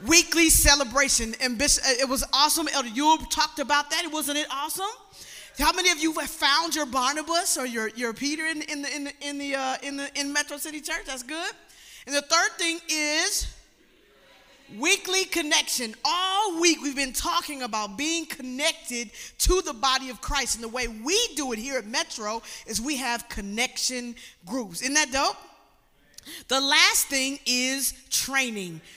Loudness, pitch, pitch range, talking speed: -24 LUFS, 285 Hz, 255-320 Hz, 150 wpm